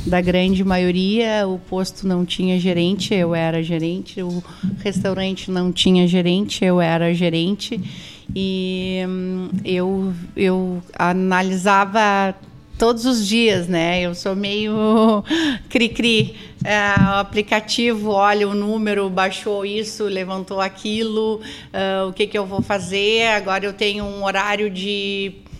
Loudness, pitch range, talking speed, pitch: -19 LUFS, 185-210 Hz, 125 wpm, 195 Hz